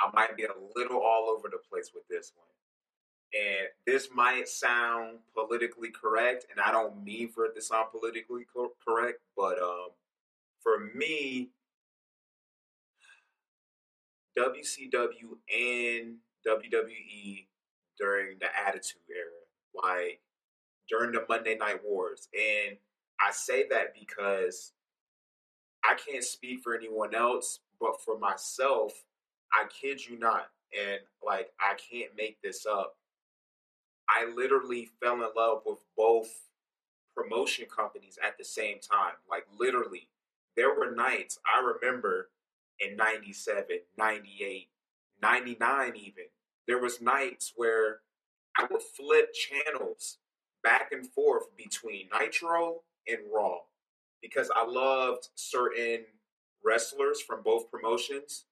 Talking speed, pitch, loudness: 120 wpm, 170 Hz, -31 LUFS